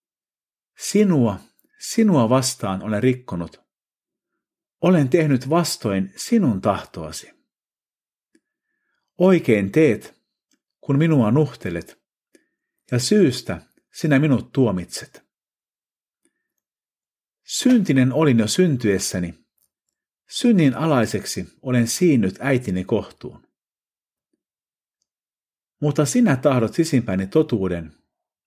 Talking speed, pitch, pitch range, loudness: 75 wpm, 130 Hz, 110-170 Hz, -20 LUFS